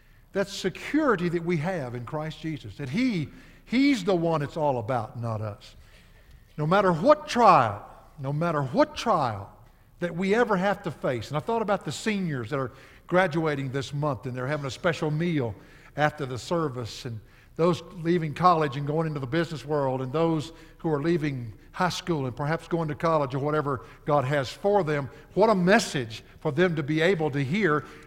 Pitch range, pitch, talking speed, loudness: 135-175 Hz, 155 Hz, 190 wpm, -26 LUFS